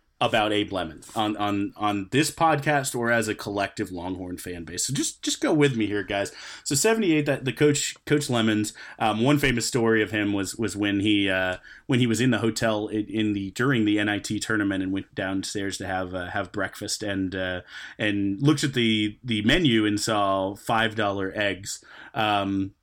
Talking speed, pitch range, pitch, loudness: 195 wpm, 100-120 Hz, 105 Hz, -25 LUFS